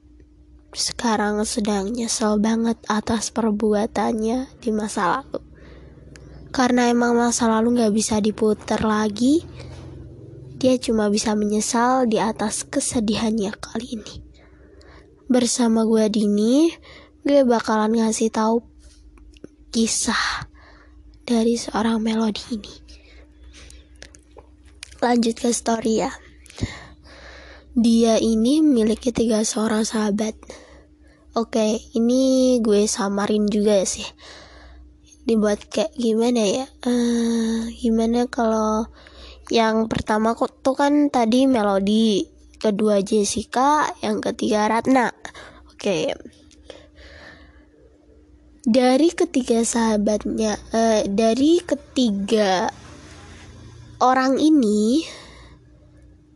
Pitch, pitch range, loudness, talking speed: 225 Hz, 210-240 Hz, -20 LUFS, 85 wpm